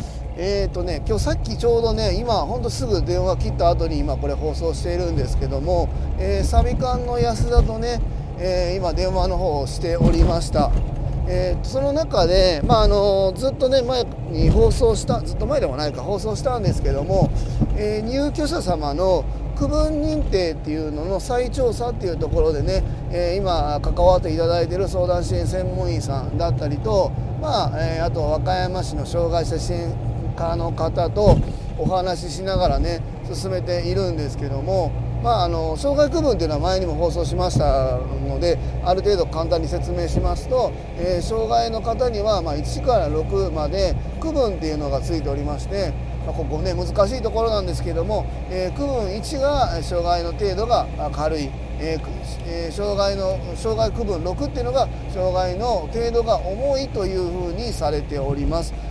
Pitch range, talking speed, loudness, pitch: 125-200 Hz, 340 characters per minute, -22 LUFS, 170 Hz